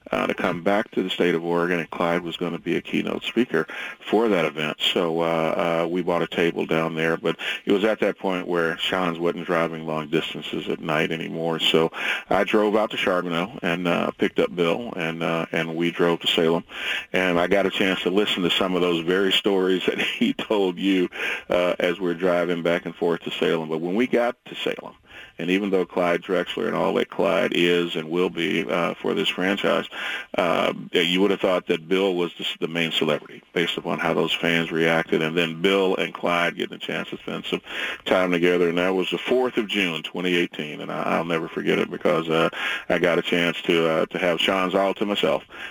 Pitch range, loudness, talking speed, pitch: 85-95 Hz, -23 LUFS, 220 wpm, 85 Hz